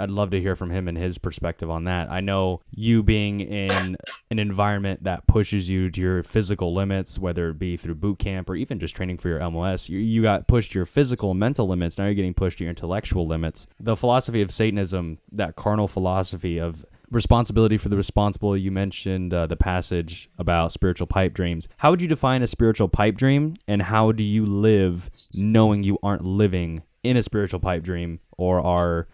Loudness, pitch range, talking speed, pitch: -23 LUFS, 90-105 Hz, 205 wpm, 95 Hz